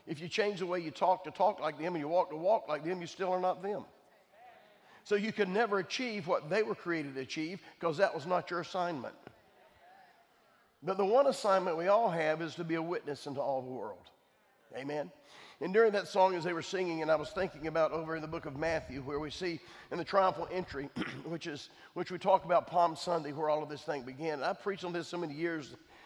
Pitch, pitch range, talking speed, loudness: 170 Hz, 155-185 Hz, 240 wpm, -34 LUFS